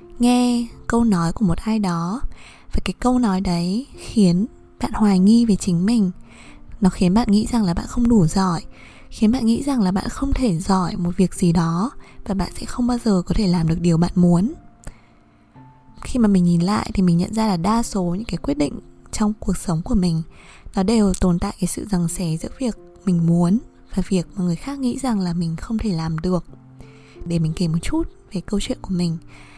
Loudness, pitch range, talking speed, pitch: -20 LUFS, 175-220 Hz, 225 wpm, 190 Hz